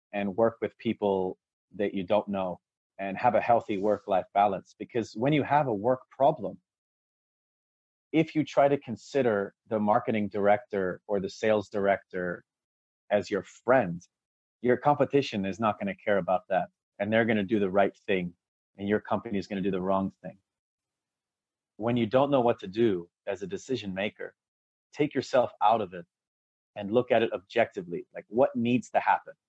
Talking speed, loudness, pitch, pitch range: 175 wpm, -28 LUFS, 105 Hz, 95-120 Hz